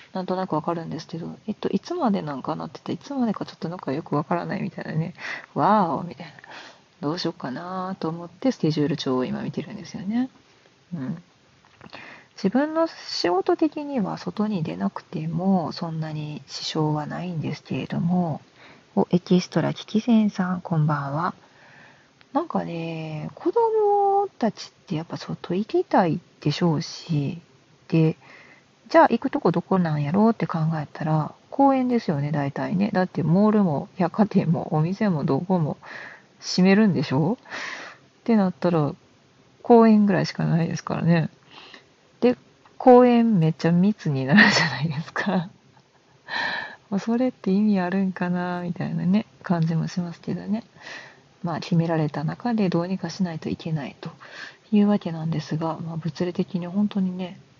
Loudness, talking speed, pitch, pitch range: -24 LUFS, 335 characters per minute, 180 Hz, 160-210 Hz